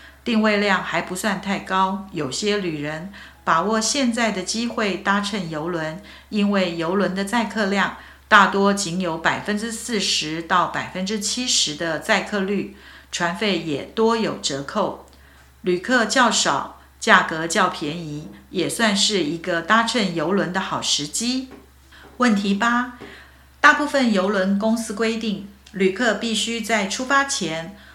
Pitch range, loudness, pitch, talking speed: 175-225 Hz, -21 LUFS, 200 Hz, 215 characters per minute